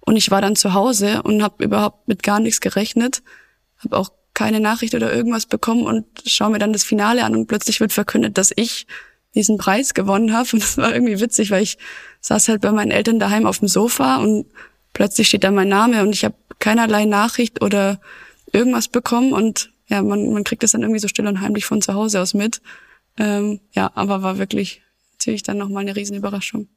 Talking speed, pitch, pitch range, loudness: 210 wpm, 215 Hz, 200-230 Hz, -17 LUFS